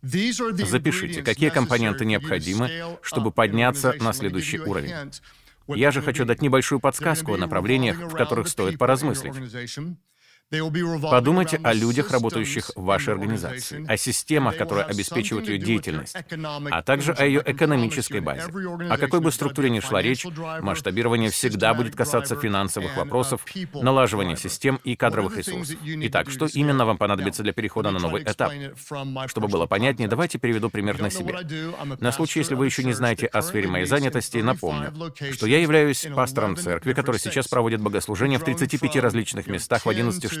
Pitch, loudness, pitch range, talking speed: 125 Hz, -23 LUFS, 110-145 Hz, 155 wpm